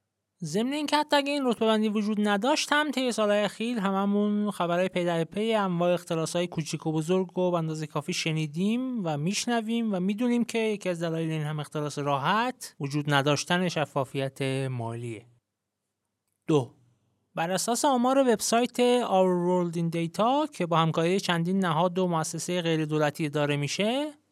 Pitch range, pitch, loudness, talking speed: 150-220 Hz, 180 Hz, -27 LUFS, 160 wpm